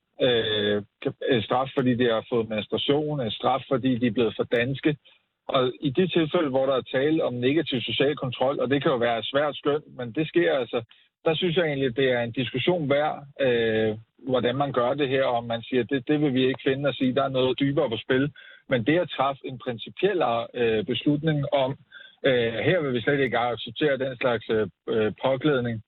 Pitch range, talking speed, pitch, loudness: 120-145 Hz, 215 wpm, 130 Hz, -25 LUFS